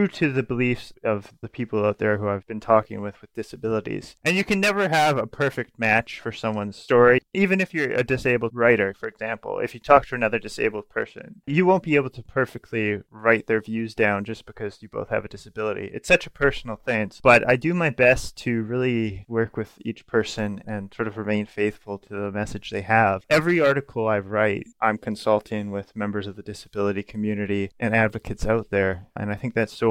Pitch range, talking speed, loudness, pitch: 105-125 Hz, 210 wpm, -23 LUFS, 110 Hz